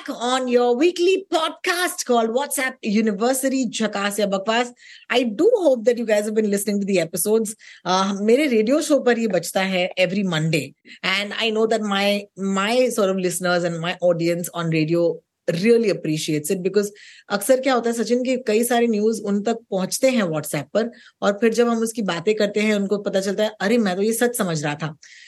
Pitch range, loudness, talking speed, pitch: 190-240 Hz, -21 LUFS, 200 wpm, 215 Hz